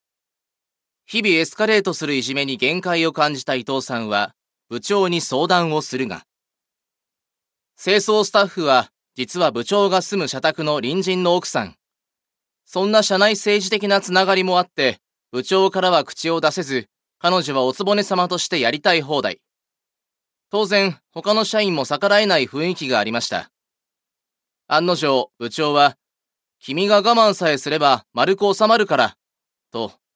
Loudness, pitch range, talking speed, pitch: -19 LUFS, 140-200 Hz, 290 characters per minute, 175 Hz